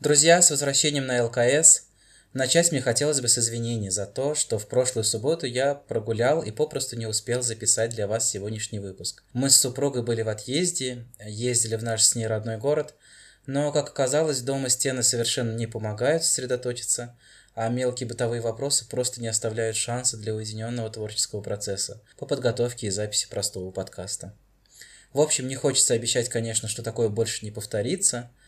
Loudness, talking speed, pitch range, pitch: -24 LUFS, 165 wpm, 110-135 Hz, 120 Hz